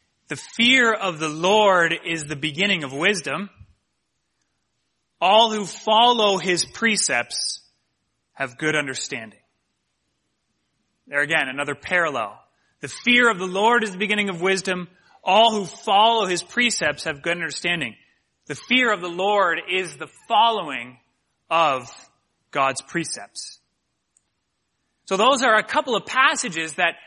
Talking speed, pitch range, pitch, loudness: 130 wpm, 155-215 Hz, 185 Hz, -20 LUFS